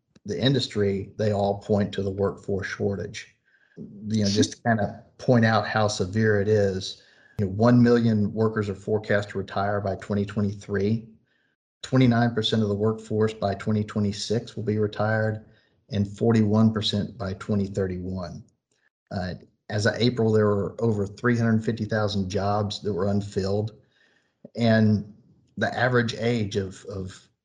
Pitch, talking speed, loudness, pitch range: 105 Hz, 140 wpm, -25 LUFS, 100-110 Hz